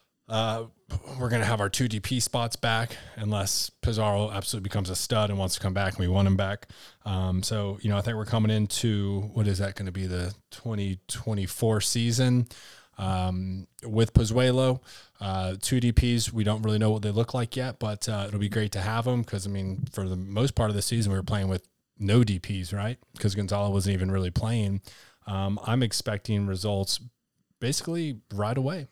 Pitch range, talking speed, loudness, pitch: 100-115 Hz, 200 wpm, -28 LUFS, 105 Hz